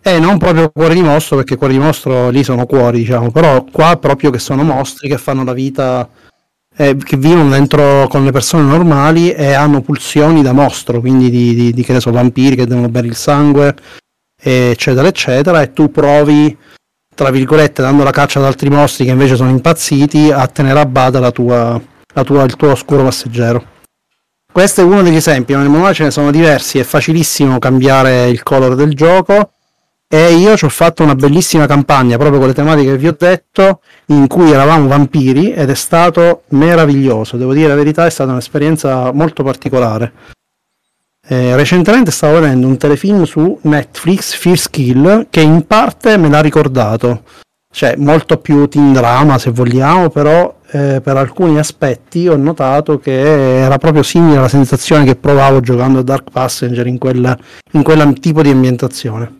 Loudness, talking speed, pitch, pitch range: -9 LUFS, 180 wpm, 140 Hz, 130-155 Hz